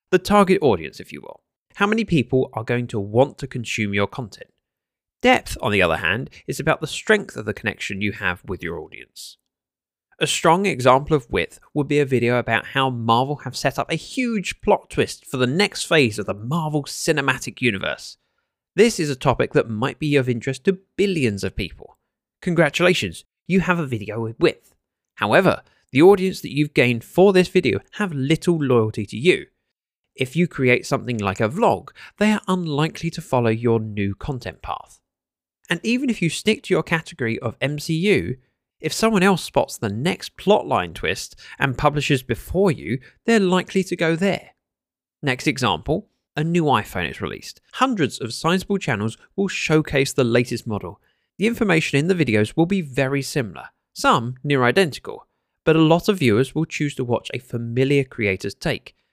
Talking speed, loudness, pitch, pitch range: 185 wpm, -21 LUFS, 140 Hz, 120-175 Hz